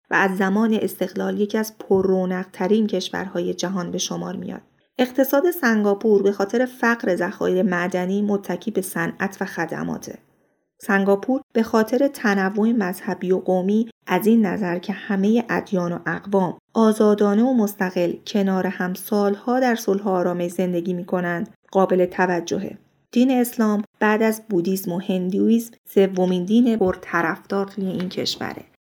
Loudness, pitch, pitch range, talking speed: -21 LUFS, 195 Hz, 185-220 Hz, 140 wpm